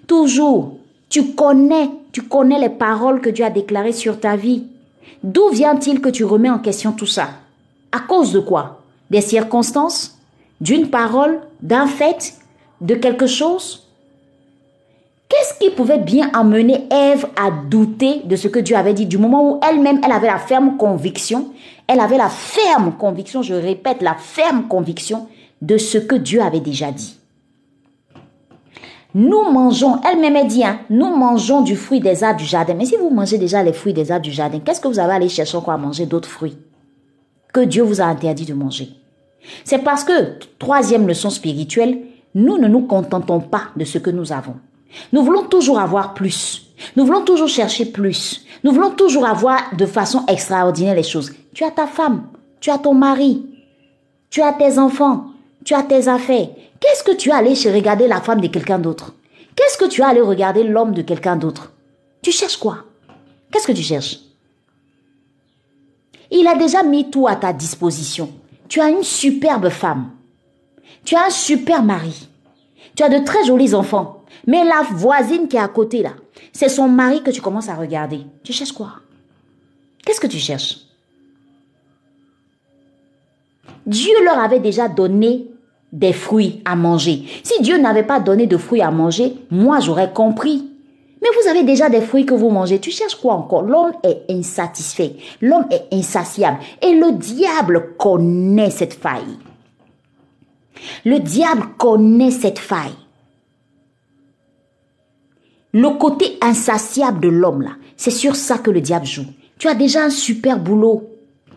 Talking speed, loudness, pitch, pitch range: 170 wpm, -15 LUFS, 230 Hz, 180-280 Hz